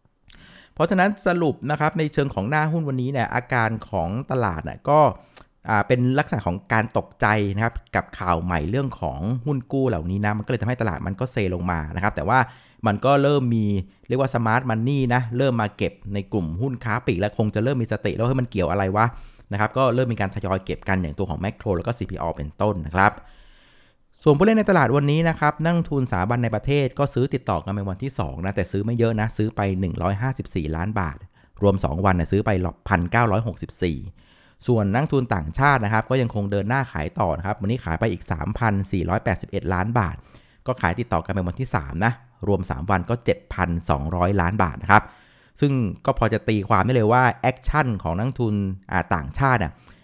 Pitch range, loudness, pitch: 95-125 Hz, -23 LUFS, 105 Hz